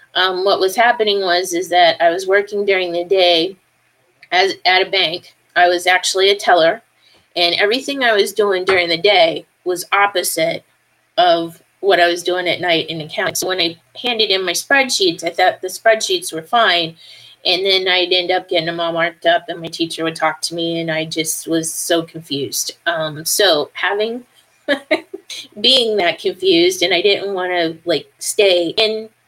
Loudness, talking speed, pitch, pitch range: -15 LUFS, 185 wpm, 185 Hz, 170-215 Hz